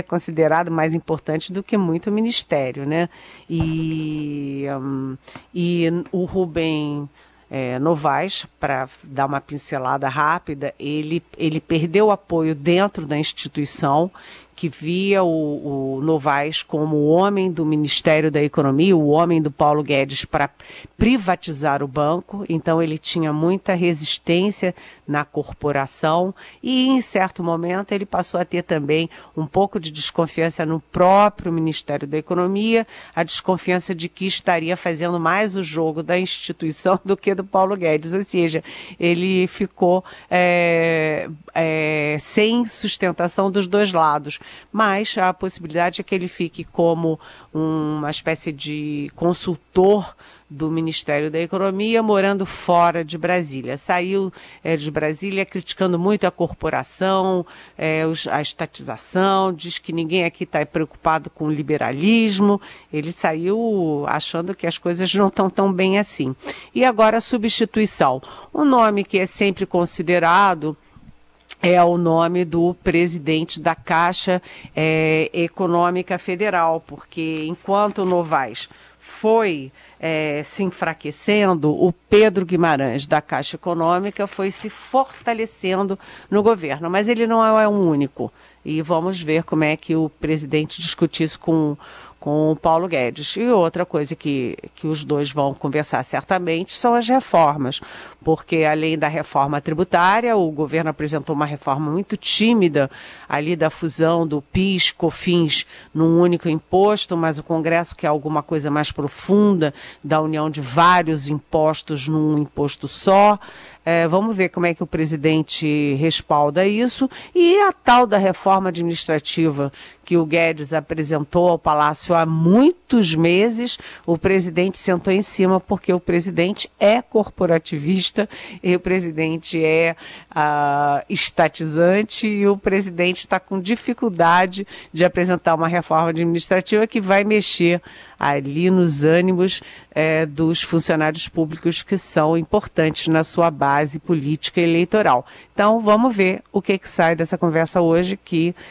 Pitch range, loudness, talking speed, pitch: 155-190 Hz, -19 LUFS, 140 wpm, 170 Hz